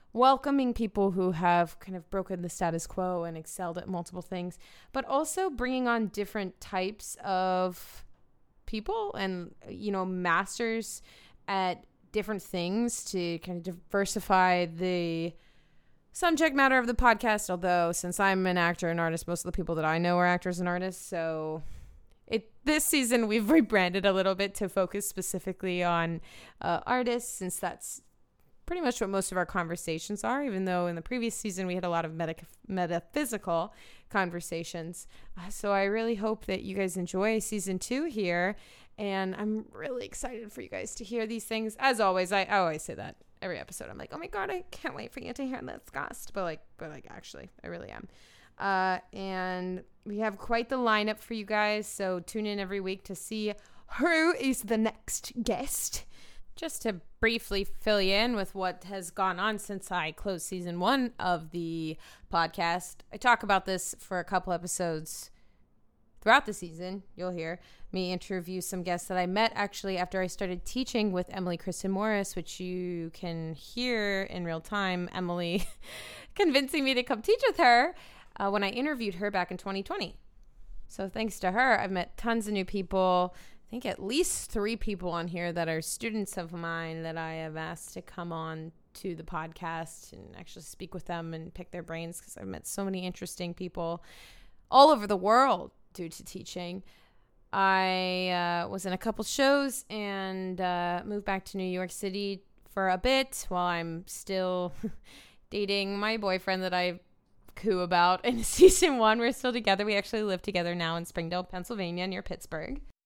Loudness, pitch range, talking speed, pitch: -30 LUFS, 175-220 Hz, 185 wpm, 190 Hz